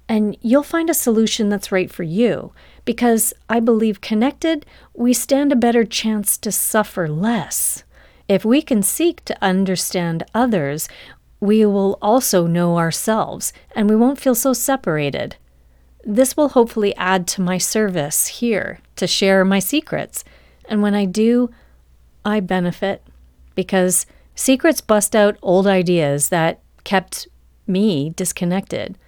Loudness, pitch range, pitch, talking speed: -18 LUFS, 185-235 Hz, 210 Hz, 140 wpm